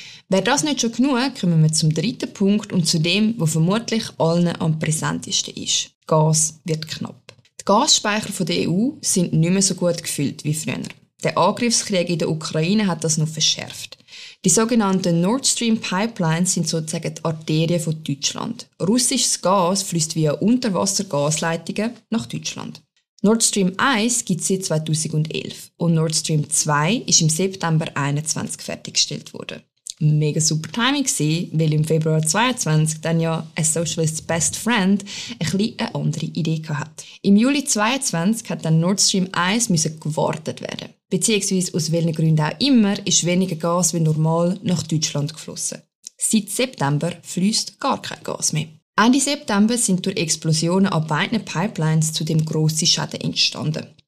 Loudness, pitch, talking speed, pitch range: -20 LUFS, 175 Hz, 160 wpm, 160-210 Hz